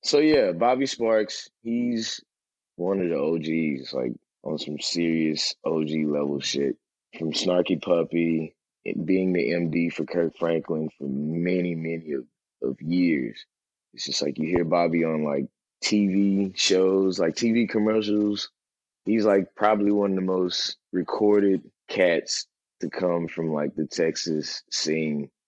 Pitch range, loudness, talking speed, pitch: 80-100 Hz, -25 LUFS, 145 wpm, 85 Hz